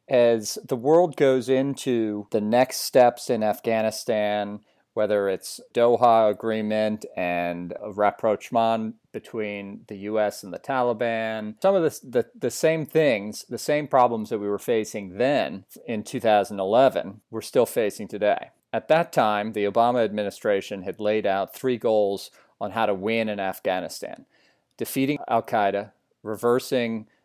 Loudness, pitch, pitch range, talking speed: -24 LUFS, 110 Hz, 105-125 Hz, 145 wpm